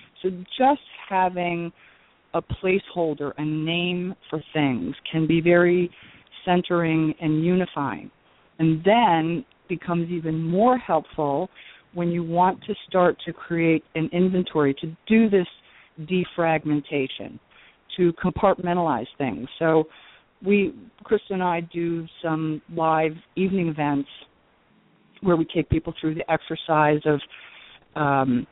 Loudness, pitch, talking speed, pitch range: -23 LUFS, 170 Hz, 115 wpm, 155-180 Hz